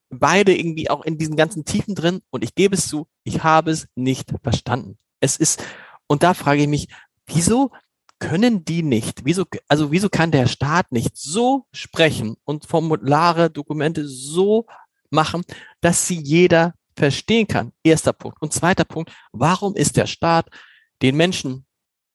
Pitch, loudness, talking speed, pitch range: 160 Hz, -19 LUFS, 160 wpm, 145-175 Hz